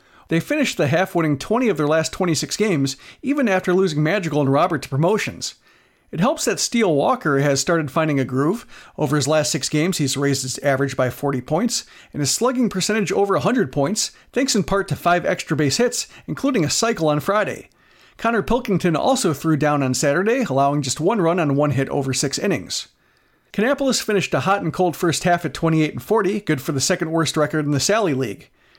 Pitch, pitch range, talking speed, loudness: 165 Hz, 145-200 Hz, 200 wpm, -20 LUFS